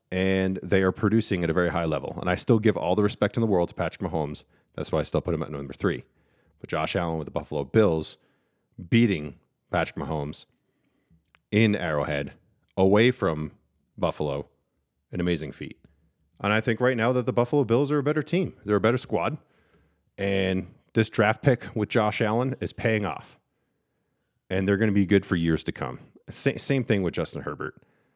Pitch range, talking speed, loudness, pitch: 80-110 Hz, 195 wpm, -26 LUFS, 95 Hz